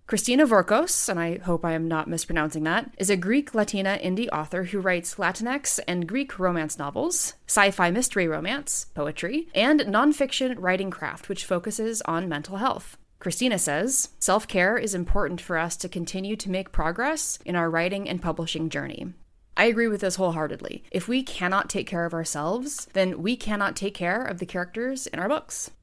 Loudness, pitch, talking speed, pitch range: -25 LUFS, 190 Hz, 185 wpm, 170-235 Hz